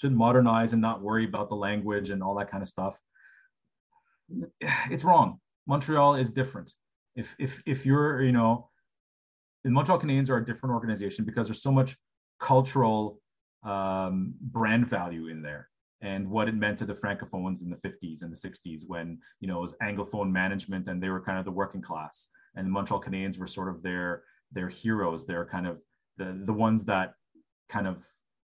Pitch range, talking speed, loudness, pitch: 95-120 Hz, 185 wpm, -29 LUFS, 100 Hz